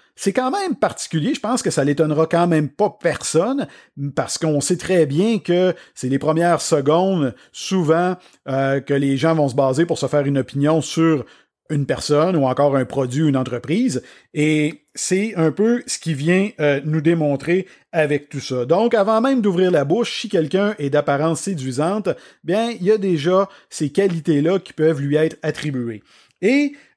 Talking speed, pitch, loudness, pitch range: 180 wpm, 160 Hz, -19 LUFS, 145-185 Hz